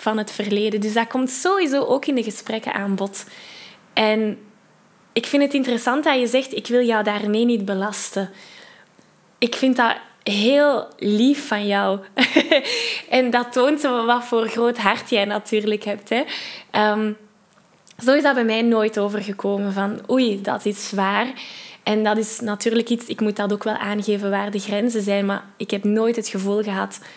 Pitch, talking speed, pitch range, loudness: 215 Hz, 175 wpm, 205-245 Hz, -20 LUFS